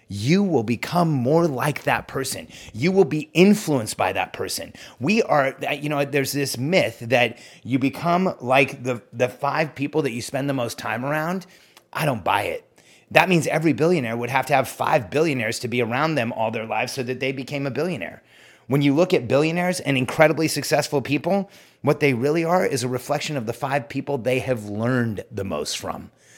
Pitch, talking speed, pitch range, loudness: 140 Hz, 200 wpm, 125-155 Hz, -22 LUFS